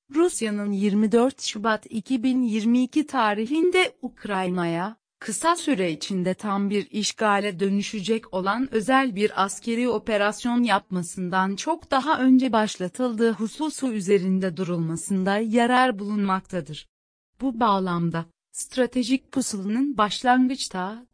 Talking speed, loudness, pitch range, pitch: 95 wpm, -24 LUFS, 195-255 Hz, 220 Hz